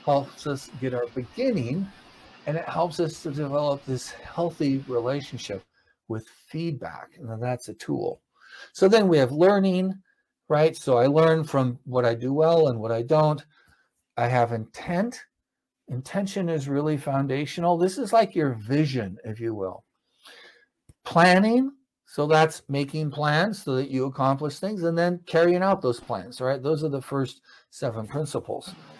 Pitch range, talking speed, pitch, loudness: 130-170 Hz, 160 wpm, 150 Hz, -25 LUFS